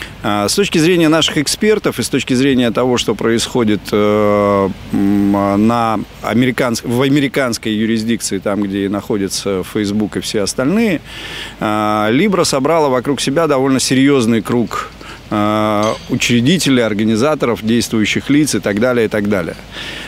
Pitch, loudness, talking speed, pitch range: 115 Hz, -14 LUFS, 125 wpm, 105-130 Hz